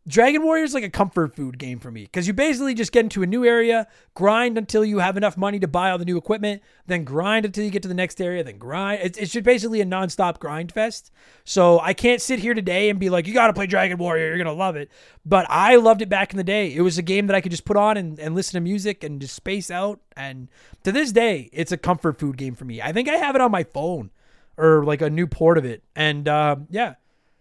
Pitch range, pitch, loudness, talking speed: 160-215 Hz, 185 Hz, -21 LUFS, 270 wpm